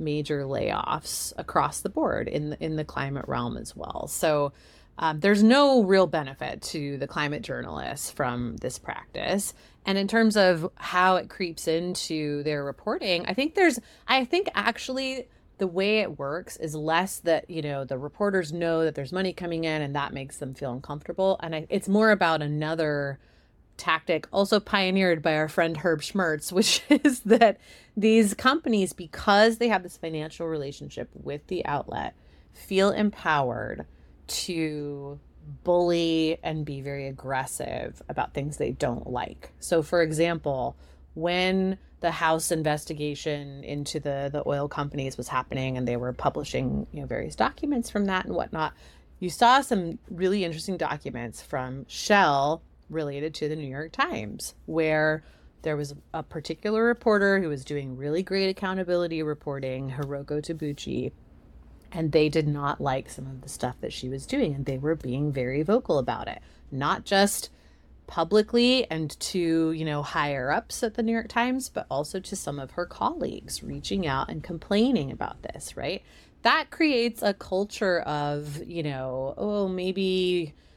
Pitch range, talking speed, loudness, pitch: 145-190 Hz, 165 wpm, -27 LUFS, 160 Hz